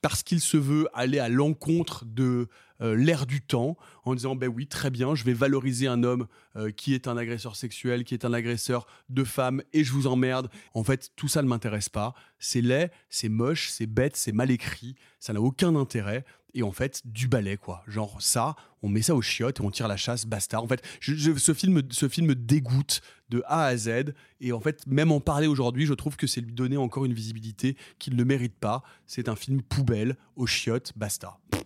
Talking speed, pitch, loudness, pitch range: 225 wpm, 125 Hz, -27 LUFS, 115-140 Hz